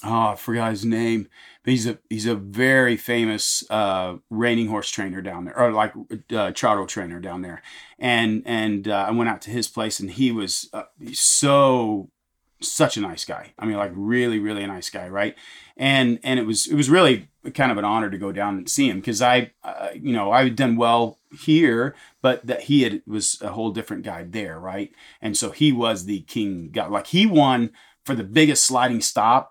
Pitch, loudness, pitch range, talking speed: 115 Hz, -21 LUFS, 105-125 Hz, 215 wpm